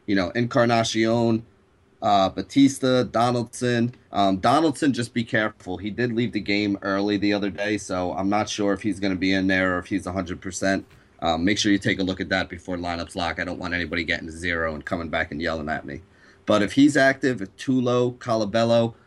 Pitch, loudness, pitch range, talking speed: 100 Hz, -23 LUFS, 95-120 Hz, 210 wpm